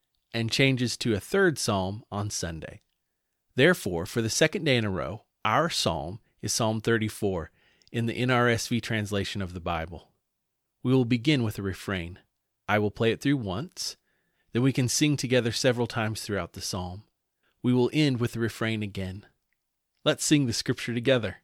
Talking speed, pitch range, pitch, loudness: 175 wpm, 100-125 Hz, 115 Hz, -27 LUFS